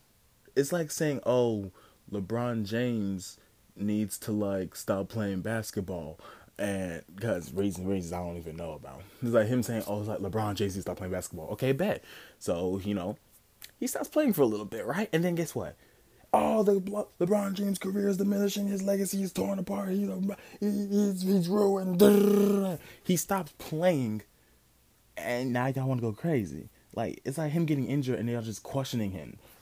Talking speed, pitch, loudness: 185 wpm, 125 Hz, -30 LUFS